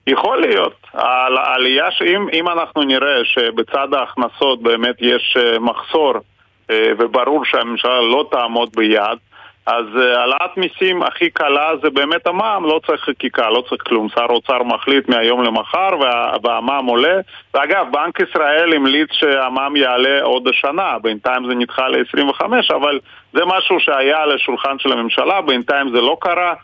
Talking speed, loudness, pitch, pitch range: 140 wpm, -15 LUFS, 130 Hz, 120-155 Hz